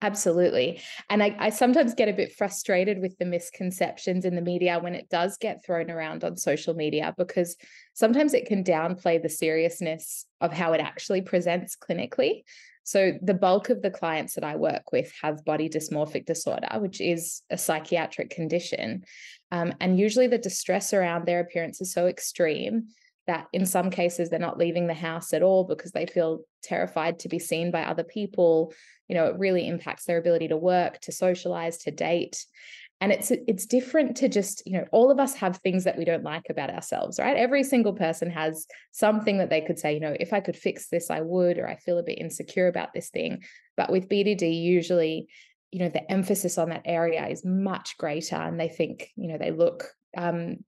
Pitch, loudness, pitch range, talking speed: 175 Hz, -26 LUFS, 165-200 Hz, 200 wpm